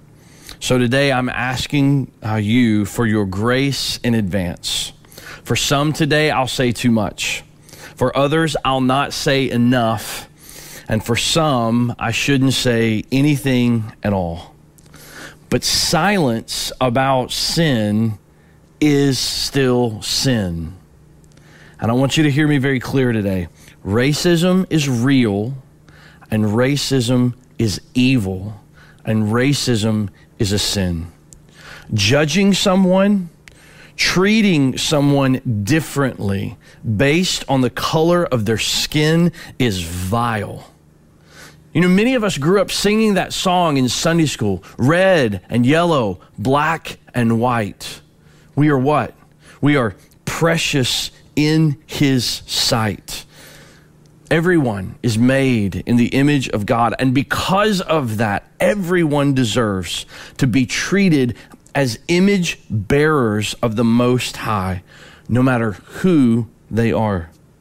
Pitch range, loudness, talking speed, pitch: 110-150 Hz, -17 LUFS, 120 wpm, 125 Hz